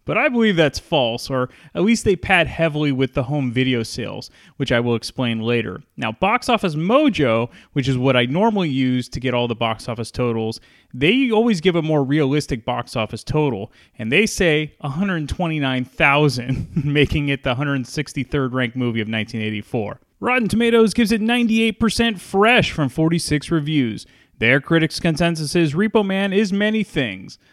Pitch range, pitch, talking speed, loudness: 125-190 Hz, 145 Hz, 170 wpm, -19 LUFS